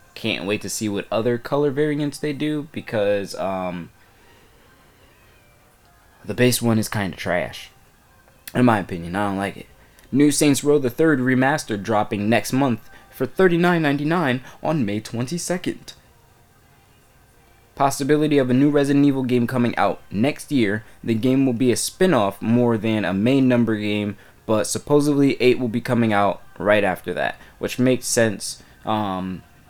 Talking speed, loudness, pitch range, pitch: 165 wpm, -21 LUFS, 105-140 Hz, 120 Hz